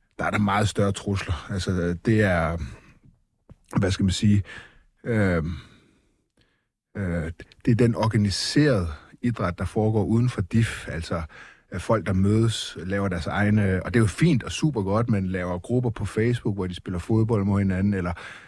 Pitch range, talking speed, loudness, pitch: 95-110 Hz, 170 wpm, -24 LUFS, 100 Hz